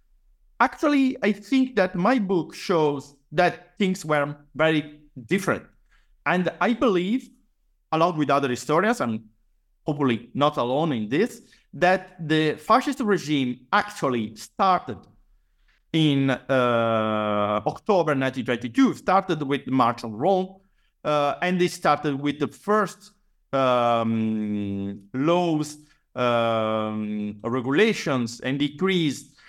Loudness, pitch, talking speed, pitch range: -24 LUFS, 150 Hz, 110 wpm, 125-185 Hz